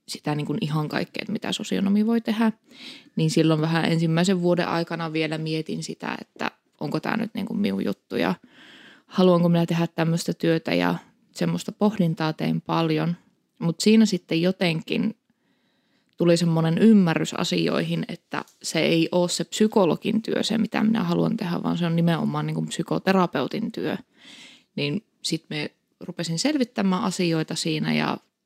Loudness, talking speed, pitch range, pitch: -24 LUFS, 155 wpm, 165-220 Hz, 175 Hz